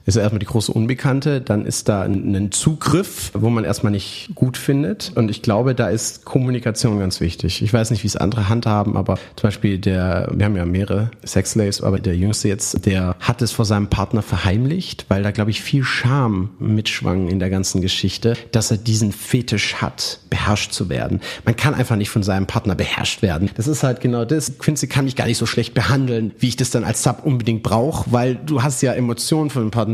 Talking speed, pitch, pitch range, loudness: 220 wpm, 110 Hz, 100-125 Hz, -19 LUFS